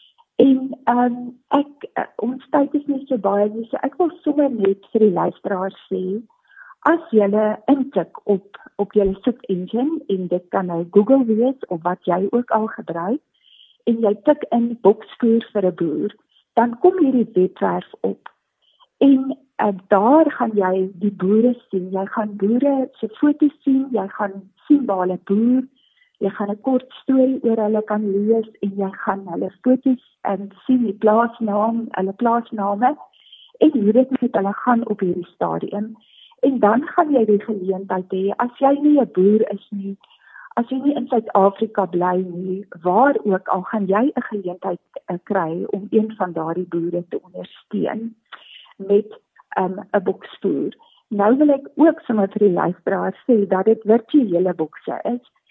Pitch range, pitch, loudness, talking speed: 195-260 Hz, 220 Hz, -19 LUFS, 175 wpm